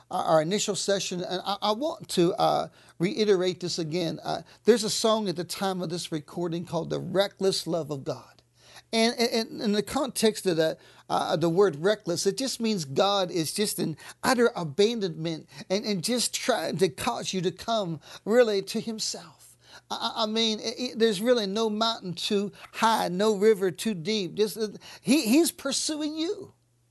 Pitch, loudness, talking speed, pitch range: 200 Hz, -27 LUFS, 185 wpm, 175-225 Hz